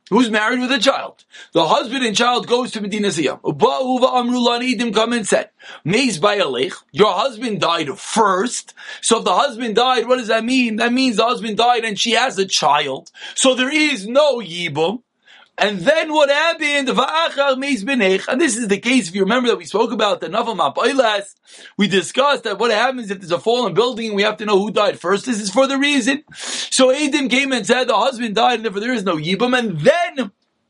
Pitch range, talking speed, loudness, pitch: 210-260 Hz, 210 wpm, -17 LUFS, 240 Hz